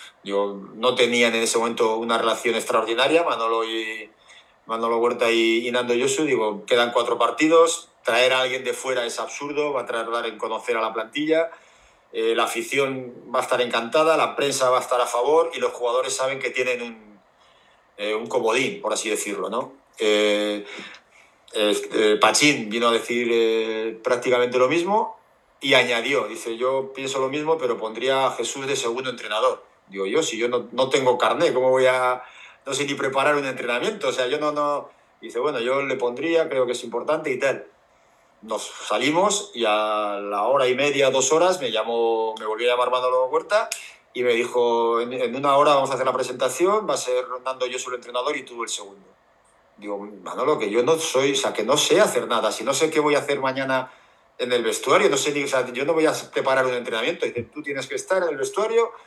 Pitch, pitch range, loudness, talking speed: 125 Hz, 115-140 Hz, -22 LUFS, 210 wpm